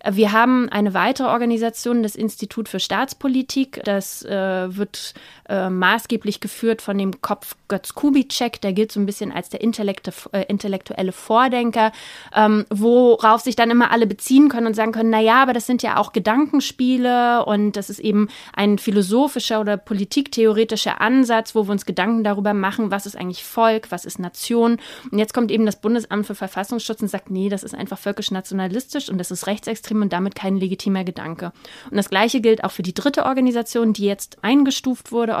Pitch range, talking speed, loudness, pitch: 200-235 Hz, 180 wpm, -19 LUFS, 215 Hz